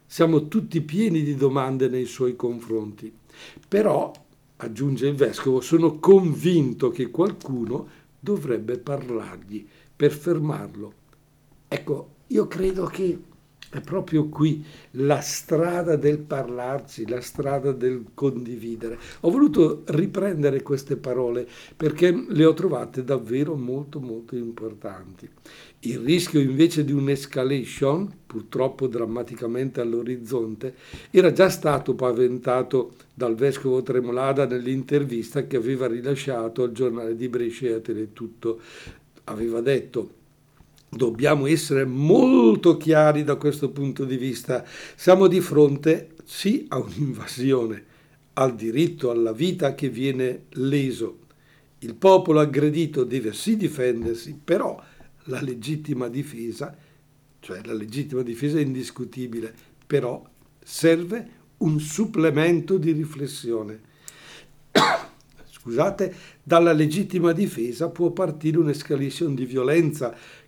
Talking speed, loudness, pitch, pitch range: 110 wpm, -23 LUFS, 140 Hz, 125-160 Hz